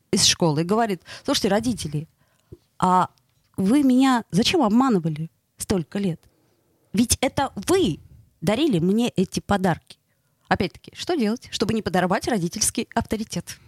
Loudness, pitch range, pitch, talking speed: -22 LUFS, 160-230 Hz, 190 Hz, 125 wpm